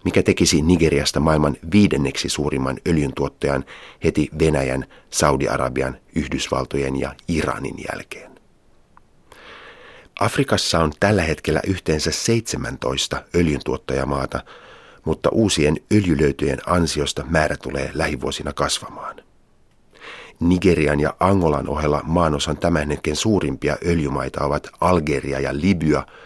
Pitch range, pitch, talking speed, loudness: 70-85 Hz, 75 Hz, 95 wpm, -20 LUFS